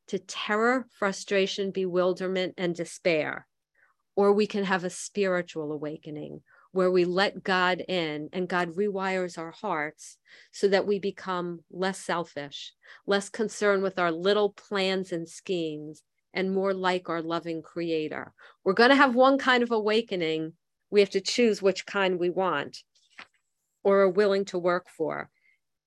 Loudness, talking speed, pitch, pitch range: -27 LUFS, 150 wpm, 190 Hz, 170-200 Hz